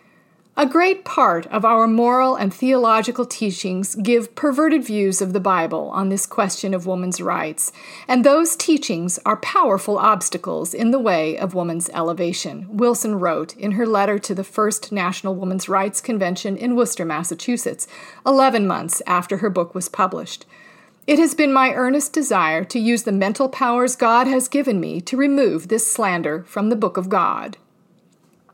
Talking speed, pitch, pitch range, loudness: 165 wpm, 215 Hz, 185-250 Hz, -19 LUFS